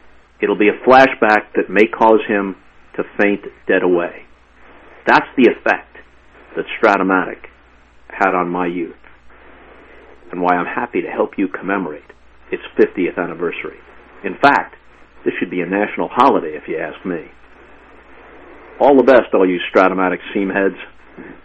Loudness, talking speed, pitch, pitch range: -16 LUFS, 145 wpm, 95 Hz, 90-130 Hz